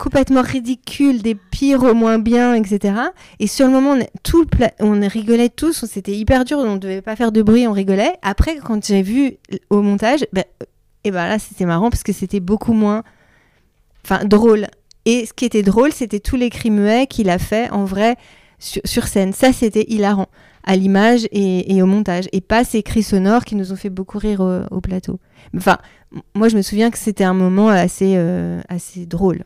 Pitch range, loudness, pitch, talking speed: 195-235 Hz, -16 LUFS, 210 Hz, 215 wpm